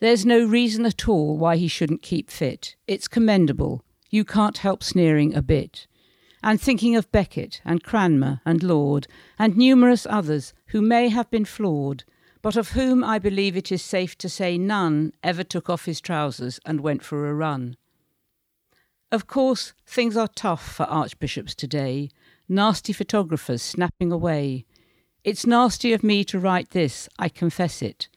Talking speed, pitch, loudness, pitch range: 165 wpm, 180 Hz, -22 LUFS, 155-215 Hz